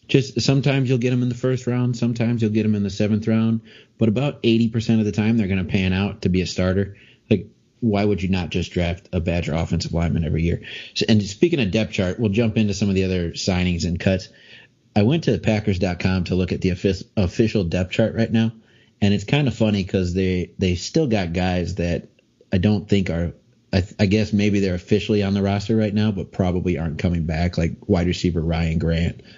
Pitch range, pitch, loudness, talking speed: 90-110 Hz, 100 Hz, -21 LUFS, 230 wpm